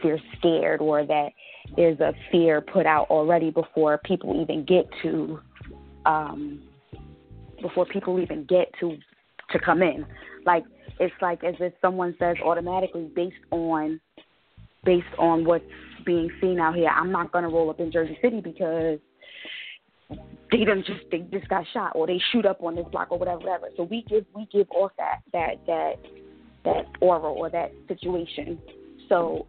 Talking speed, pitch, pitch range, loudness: 165 wpm, 170 Hz, 155-180 Hz, -25 LUFS